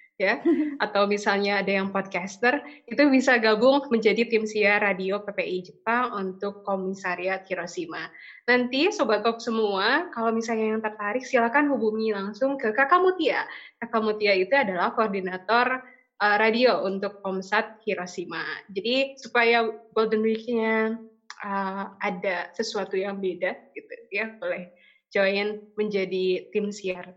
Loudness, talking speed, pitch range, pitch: -25 LUFS, 130 wpm, 195-235 Hz, 215 Hz